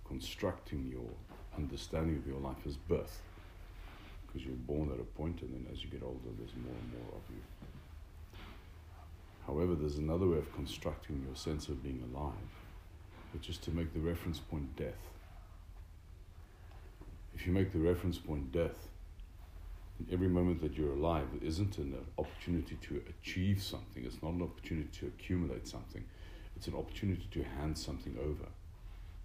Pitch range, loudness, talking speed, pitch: 75-90 Hz, -40 LUFS, 160 wpm, 85 Hz